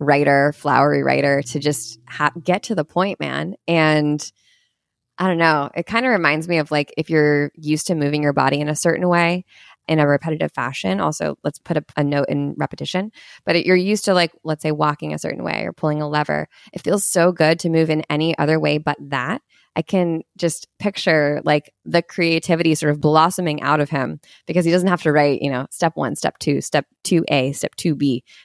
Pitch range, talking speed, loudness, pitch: 145-170 Hz, 215 wpm, -19 LUFS, 155 Hz